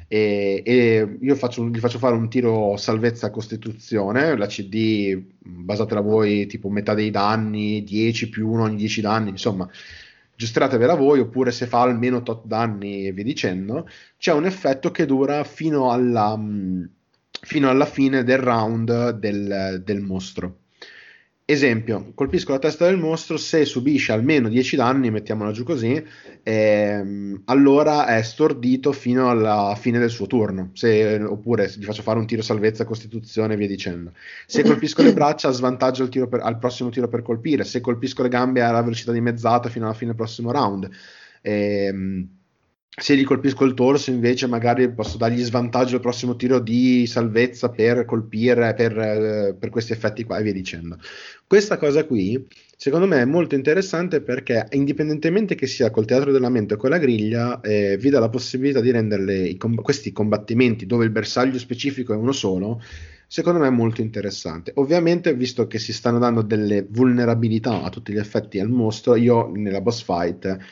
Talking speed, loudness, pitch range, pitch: 170 wpm, -20 LUFS, 105-130 Hz, 115 Hz